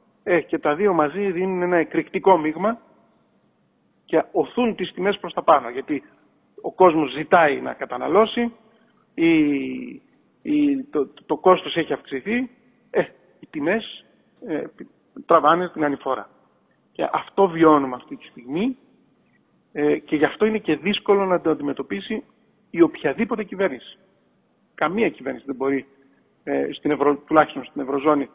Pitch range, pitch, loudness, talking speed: 150-225 Hz, 180 Hz, -21 LUFS, 140 wpm